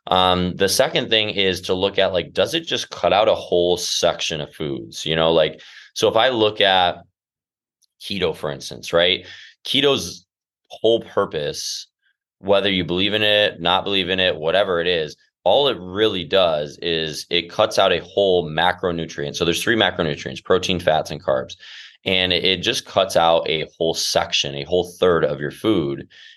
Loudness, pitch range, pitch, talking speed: -19 LUFS, 85-100 Hz, 90 Hz, 180 wpm